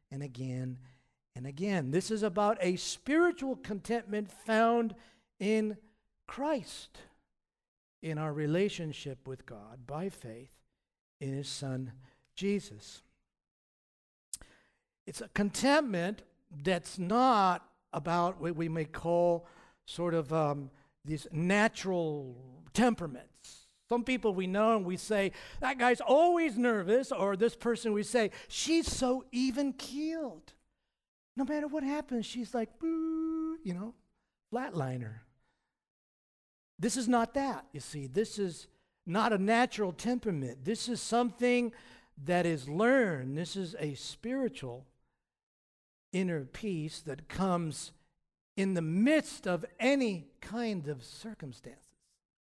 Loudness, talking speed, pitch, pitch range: -33 LUFS, 120 wpm, 195 Hz, 150-235 Hz